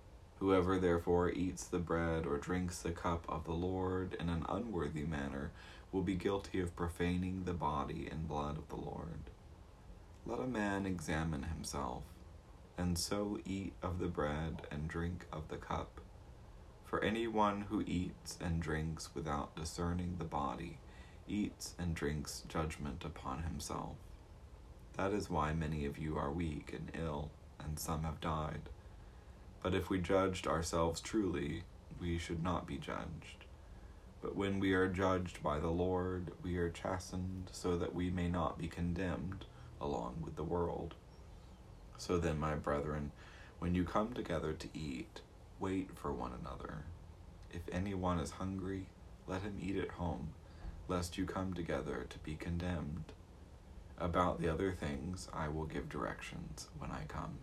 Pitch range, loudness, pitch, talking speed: 80-90 Hz, -40 LUFS, 85 Hz, 155 wpm